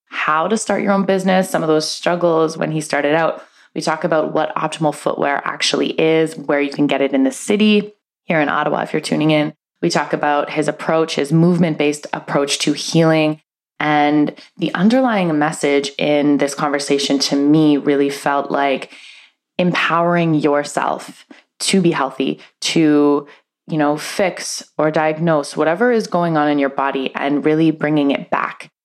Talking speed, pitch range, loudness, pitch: 175 wpm, 145-165 Hz, -17 LUFS, 155 Hz